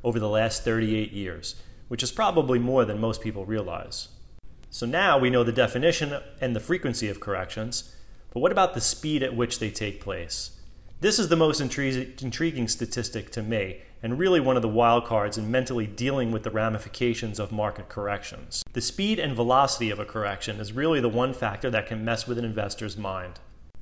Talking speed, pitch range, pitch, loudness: 195 wpm, 105-130 Hz, 115 Hz, -26 LUFS